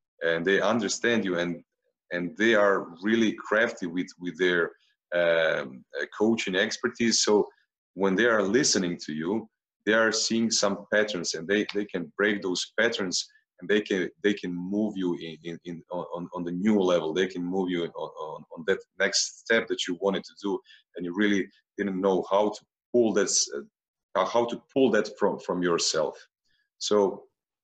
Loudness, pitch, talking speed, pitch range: -26 LUFS, 100 Hz, 180 wpm, 90-115 Hz